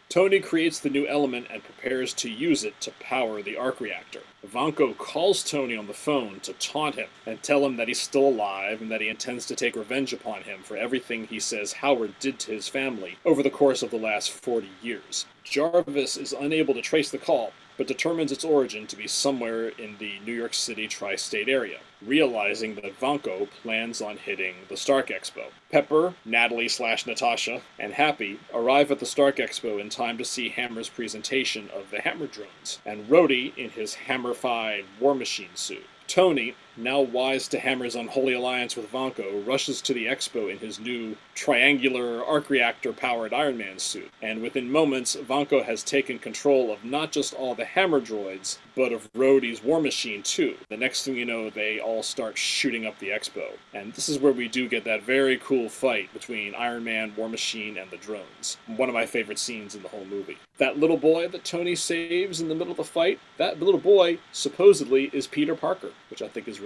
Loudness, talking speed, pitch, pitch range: -26 LUFS, 200 wpm, 130 Hz, 115-145 Hz